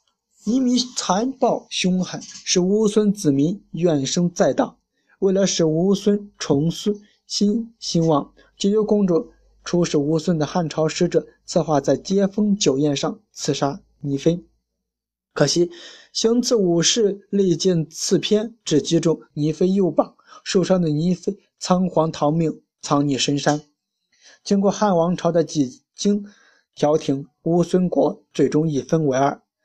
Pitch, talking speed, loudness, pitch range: 175 Hz, 200 characters per minute, -20 LUFS, 155-205 Hz